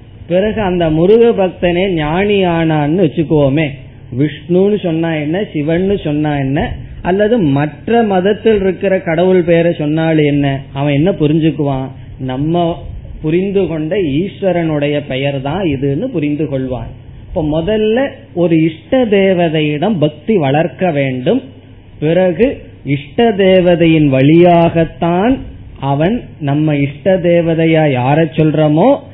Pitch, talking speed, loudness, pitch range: 160 Hz, 95 wpm, -13 LUFS, 145-185 Hz